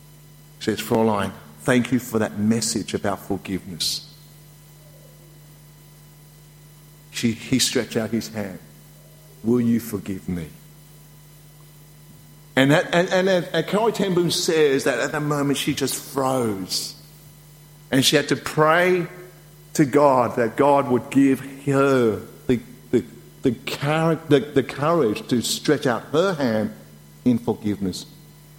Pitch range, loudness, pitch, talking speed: 120-150 Hz, -21 LUFS, 150 Hz, 125 wpm